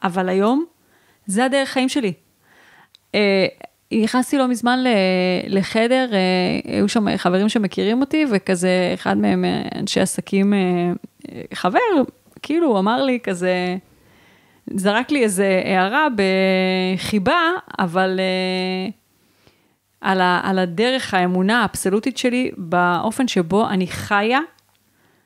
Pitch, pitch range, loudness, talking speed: 200 Hz, 185-250 Hz, -19 LUFS, 115 wpm